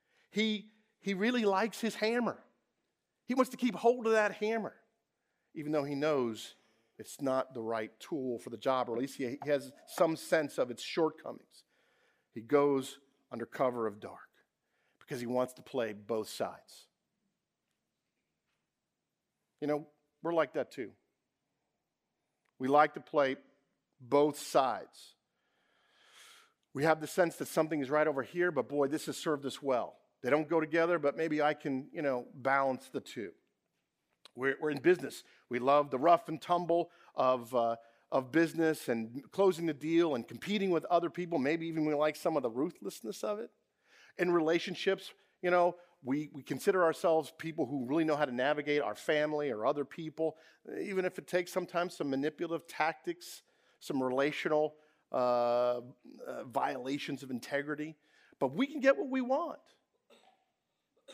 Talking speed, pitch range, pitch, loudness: 165 wpm, 135-175 Hz, 150 Hz, -33 LUFS